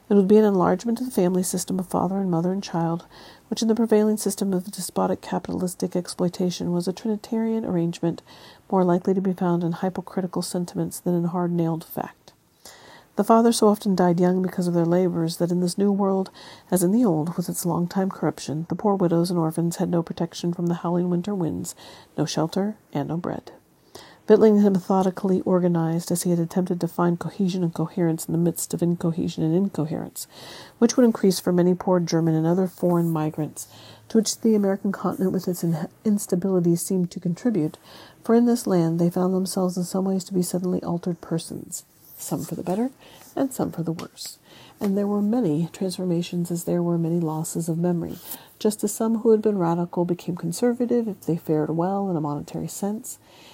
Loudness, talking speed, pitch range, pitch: -23 LUFS, 200 wpm, 170-195 Hz, 180 Hz